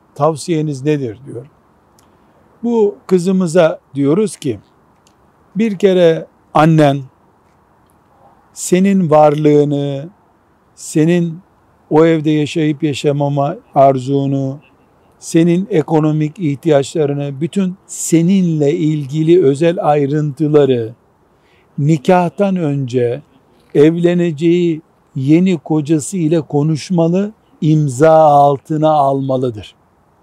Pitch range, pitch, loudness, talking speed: 140-170 Hz, 155 Hz, -14 LUFS, 70 wpm